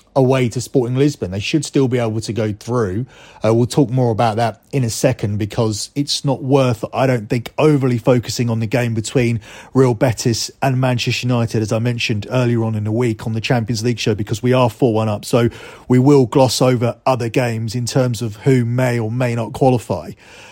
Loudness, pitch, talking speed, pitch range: -17 LUFS, 120 Hz, 225 wpm, 115-130 Hz